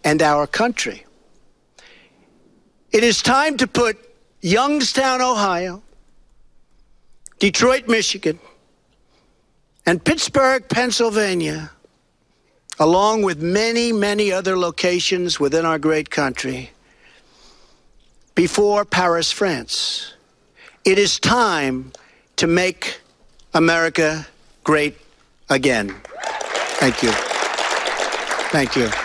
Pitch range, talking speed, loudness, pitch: 155-225 Hz, 85 wpm, -18 LUFS, 185 Hz